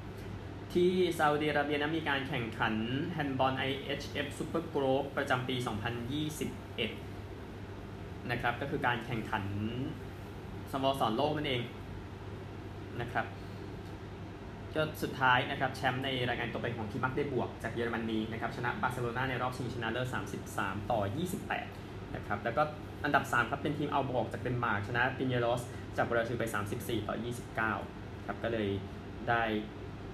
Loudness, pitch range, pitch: -34 LUFS, 100-130 Hz, 115 Hz